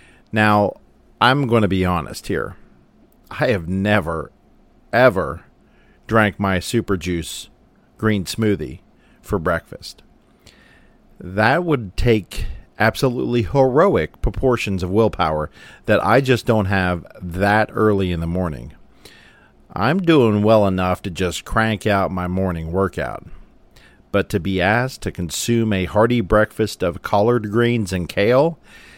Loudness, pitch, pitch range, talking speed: -19 LUFS, 100 Hz, 90-110 Hz, 130 wpm